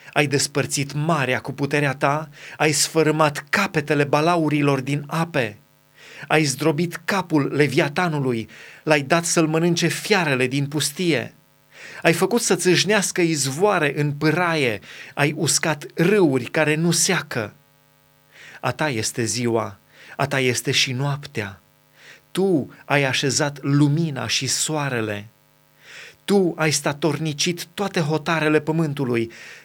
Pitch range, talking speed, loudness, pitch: 140-165 Hz, 110 wpm, -21 LUFS, 150 Hz